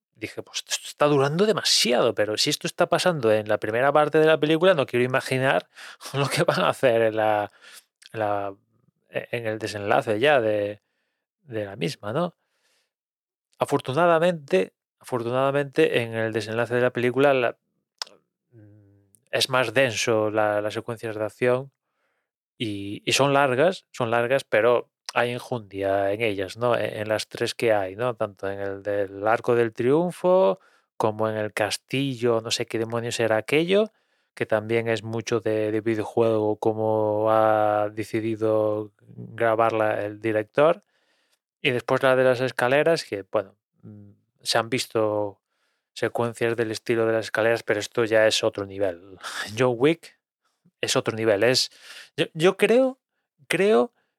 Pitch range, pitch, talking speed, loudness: 105-130 Hz, 115 Hz, 145 wpm, -23 LUFS